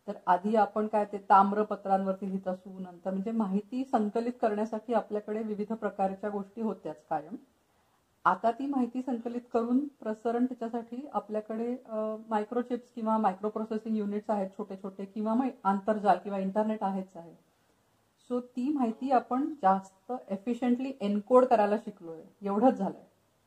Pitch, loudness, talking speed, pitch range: 215 Hz, -31 LUFS, 135 wpm, 200-240 Hz